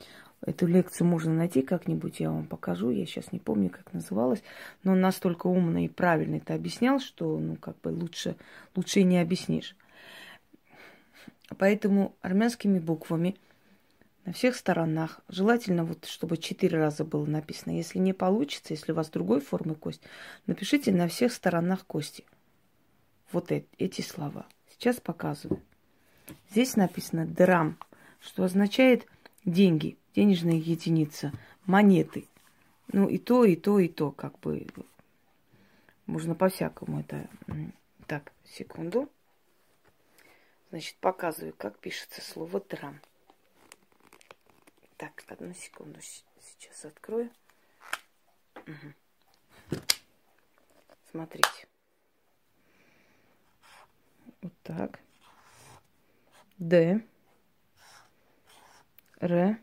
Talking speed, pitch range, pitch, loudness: 105 wpm, 160-200 Hz, 180 Hz, -28 LUFS